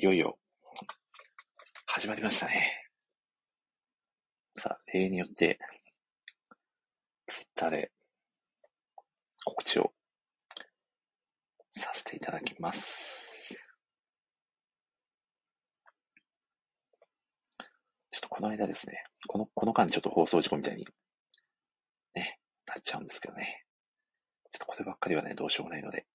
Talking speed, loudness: 220 characters per minute, -33 LUFS